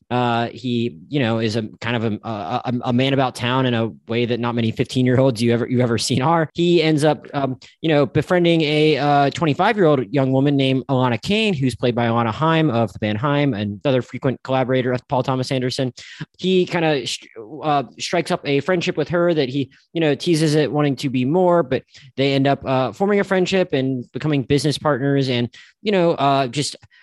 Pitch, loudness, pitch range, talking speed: 135 Hz, -19 LUFS, 125-155 Hz, 225 wpm